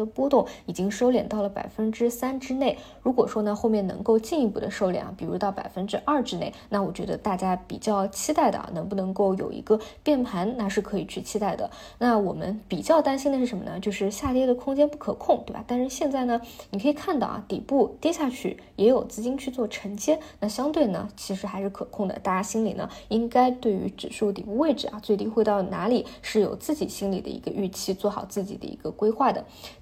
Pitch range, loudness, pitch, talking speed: 200-260 Hz, -26 LUFS, 220 Hz, 340 characters per minute